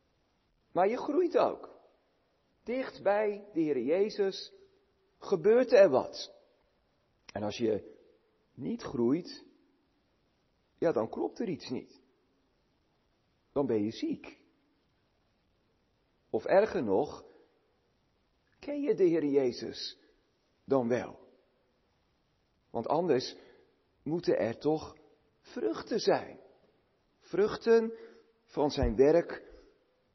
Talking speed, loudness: 95 wpm, -31 LUFS